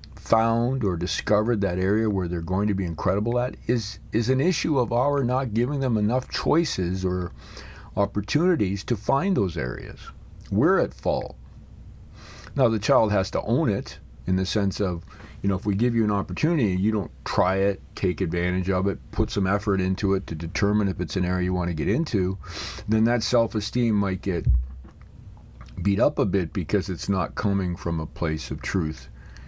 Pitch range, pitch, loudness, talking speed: 90-110 Hz, 100 Hz, -25 LUFS, 190 wpm